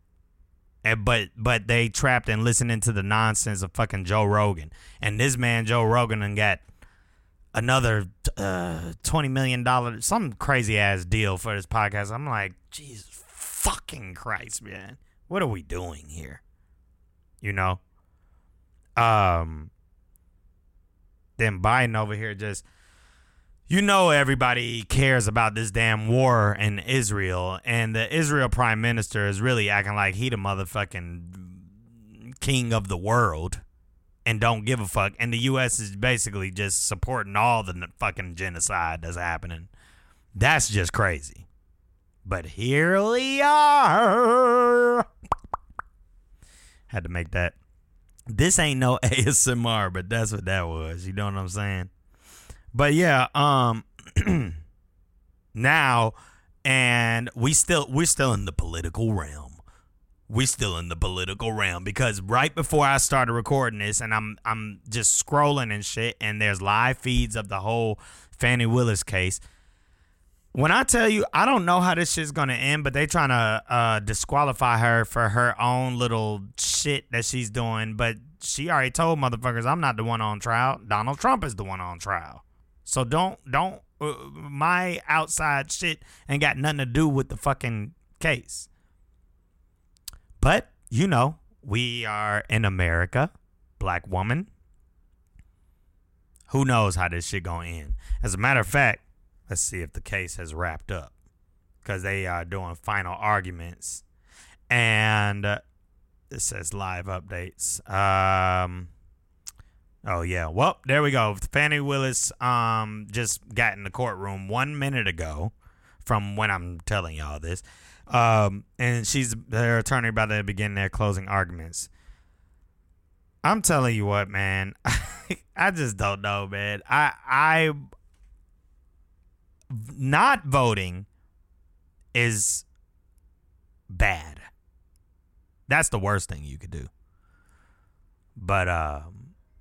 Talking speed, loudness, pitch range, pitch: 140 wpm, -24 LUFS, 85-120 Hz, 105 Hz